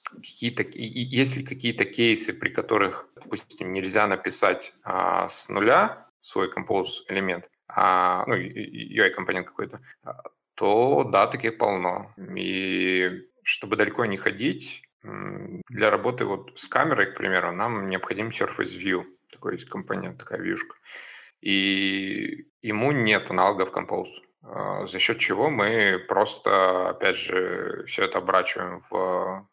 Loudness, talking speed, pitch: -24 LUFS, 125 wpm, 115 Hz